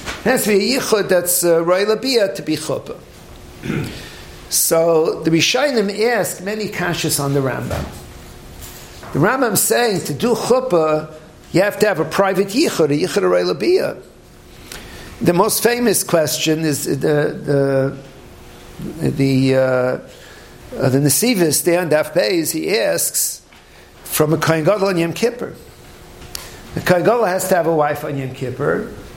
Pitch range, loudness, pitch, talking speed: 145-205 Hz, -17 LUFS, 165 Hz, 125 wpm